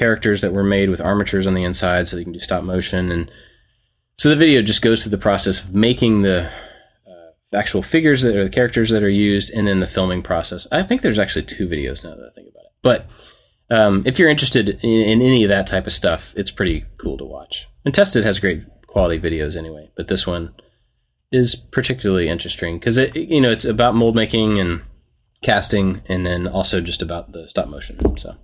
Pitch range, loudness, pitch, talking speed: 90-115 Hz, -17 LUFS, 100 Hz, 220 wpm